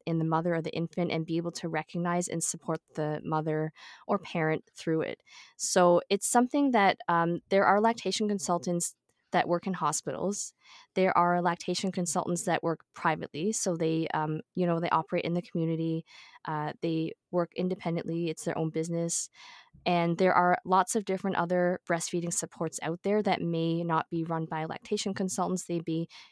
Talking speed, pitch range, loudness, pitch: 180 wpm, 165-185 Hz, -30 LUFS, 170 Hz